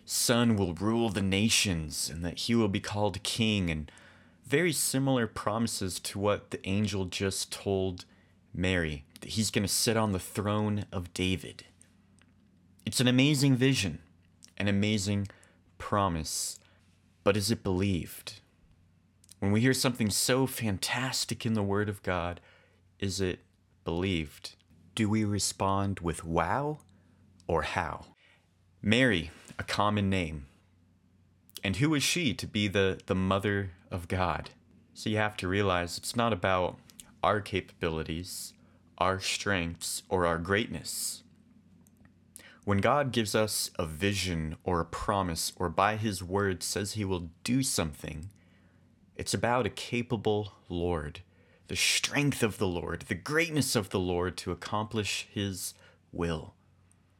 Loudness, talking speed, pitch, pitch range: -30 LUFS, 140 wpm, 95 Hz, 90-105 Hz